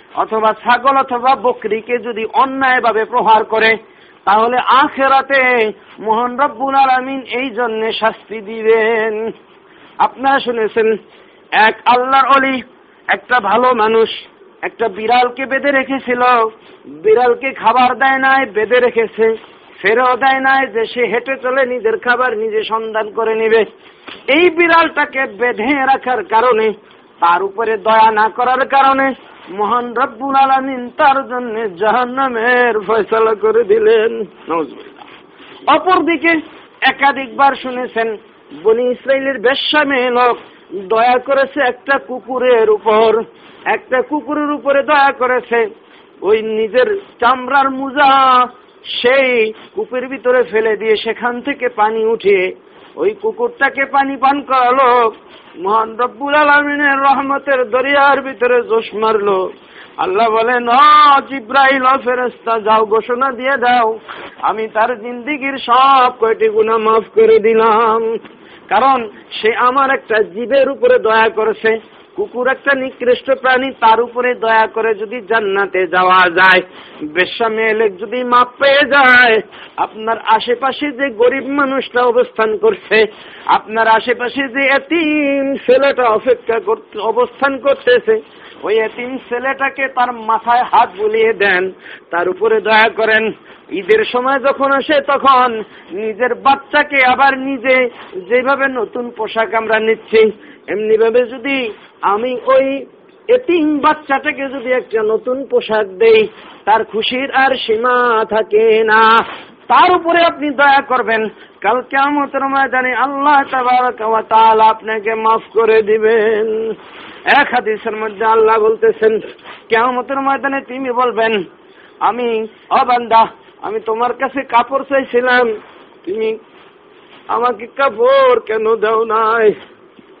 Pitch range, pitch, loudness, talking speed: 225-280 Hz, 255 Hz, -13 LUFS, 110 wpm